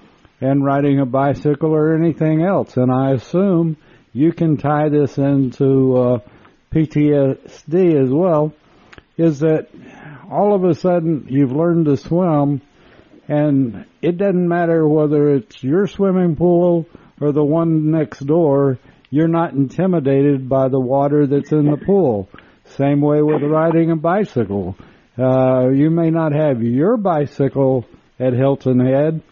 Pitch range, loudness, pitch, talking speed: 135-165 Hz, -16 LUFS, 150 Hz, 140 wpm